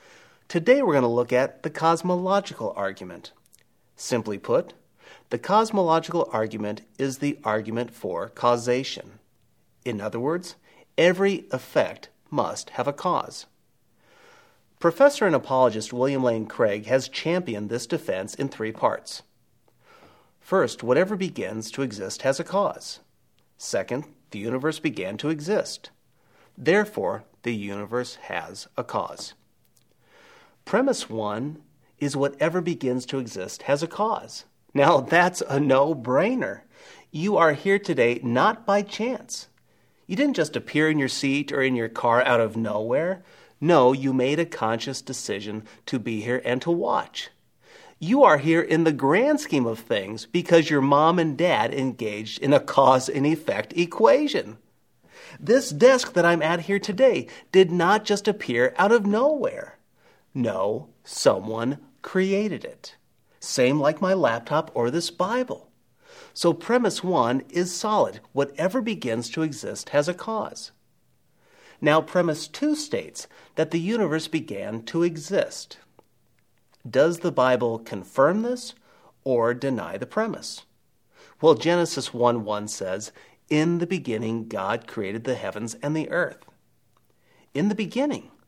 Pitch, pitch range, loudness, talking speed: 155 Hz, 125-190 Hz, -24 LUFS, 140 wpm